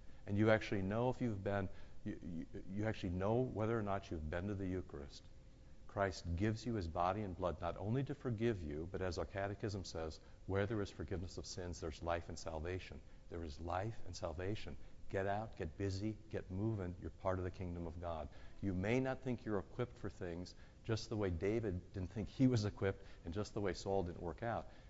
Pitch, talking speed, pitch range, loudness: 95 Hz, 215 wpm, 85-110 Hz, -42 LUFS